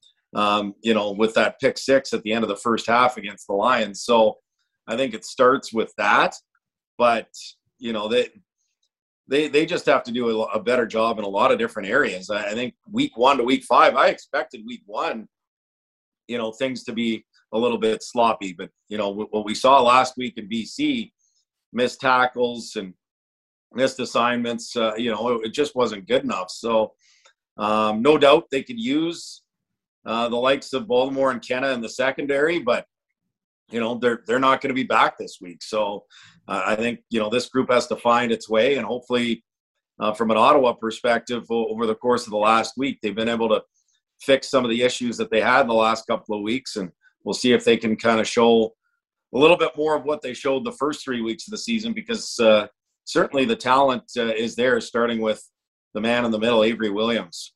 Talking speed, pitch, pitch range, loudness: 210 wpm, 115 Hz, 110-130 Hz, -21 LUFS